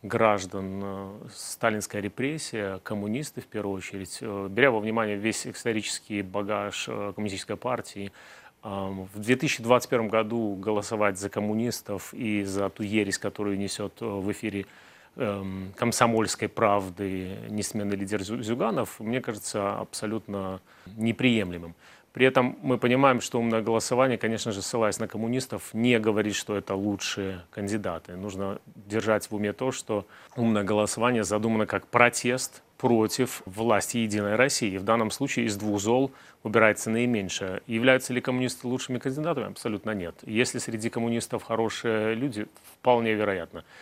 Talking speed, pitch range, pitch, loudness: 125 wpm, 100-120 Hz, 110 Hz, -27 LUFS